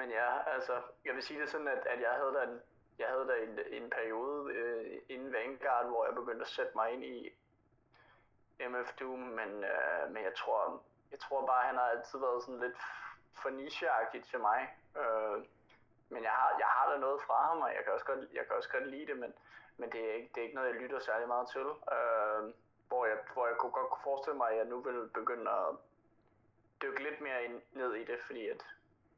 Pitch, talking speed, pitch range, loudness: 125 Hz, 230 wpm, 110-140 Hz, -37 LUFS